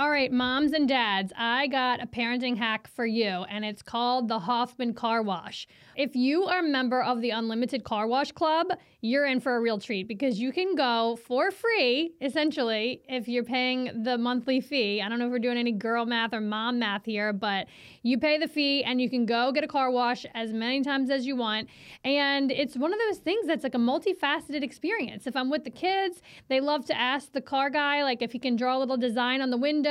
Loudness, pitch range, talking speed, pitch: -27 LUFS, 235-285 Hz, 230 wpm, 255 Hz